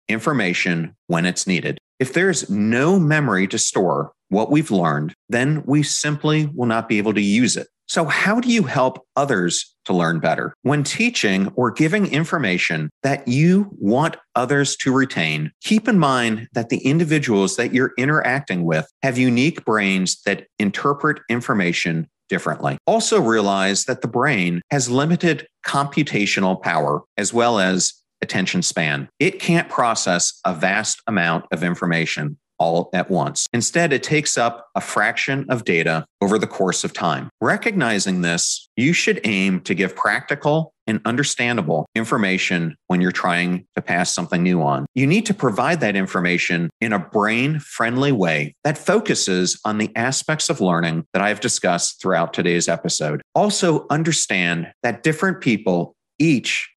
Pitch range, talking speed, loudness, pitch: 95-150 Hz, 155 wpm, -19 LUFS, 120 Hz